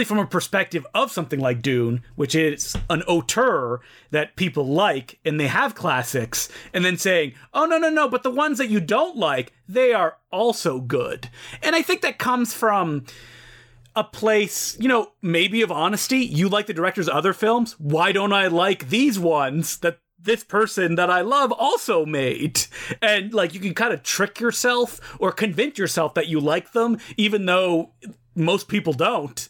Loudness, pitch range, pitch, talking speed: -21 LUFS, 160-225 Hz, 190 Hz, 180 wpm